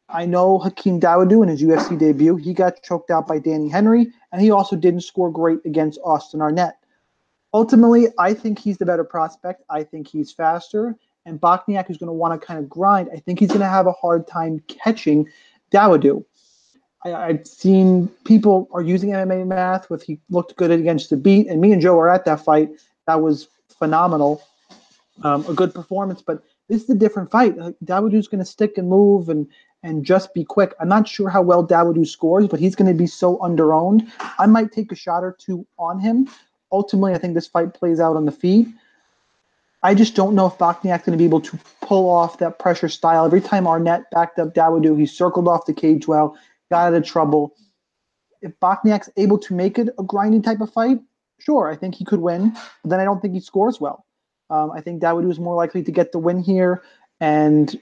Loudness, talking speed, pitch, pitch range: -18 LUFS, 210 wpm, 180 Hz, 165-200 Hz